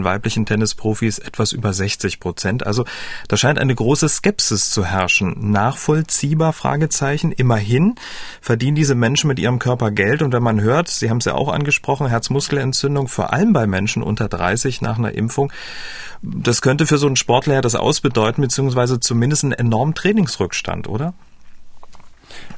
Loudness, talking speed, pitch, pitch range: -17 LUFS, 155 wpm, 125 Hz, 110-145 Hz